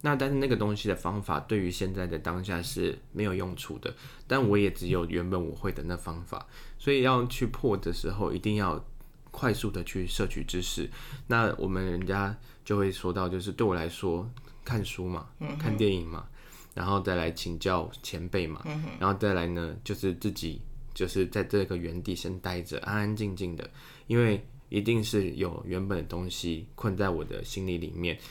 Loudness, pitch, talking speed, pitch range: -31 LUFS, 95 Hz, 275 characters per minute, 90-115 Hz